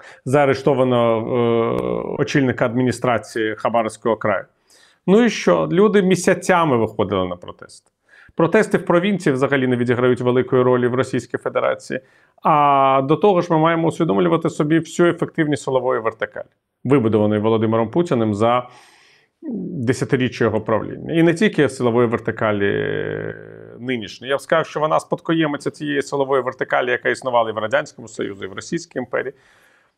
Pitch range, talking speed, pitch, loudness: 120-165 Hz, 140 wpm, 135 Hz, -19 LUFS